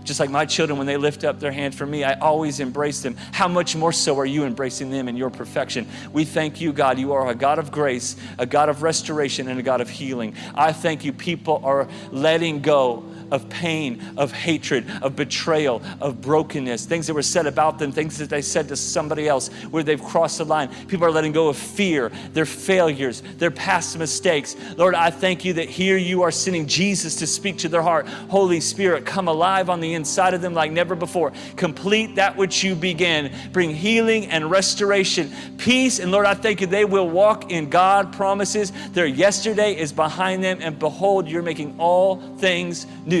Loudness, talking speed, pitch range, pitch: -21 LUFS, 210 wpm, 145-185 Hz, 165 Hz